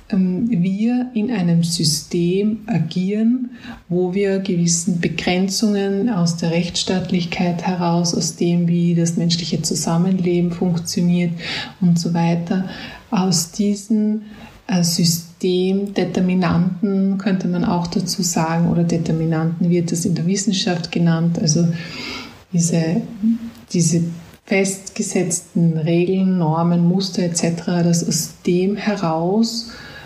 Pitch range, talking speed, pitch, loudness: 170-200 Hz, 100 wpm, 180 Hz, -19 LUFS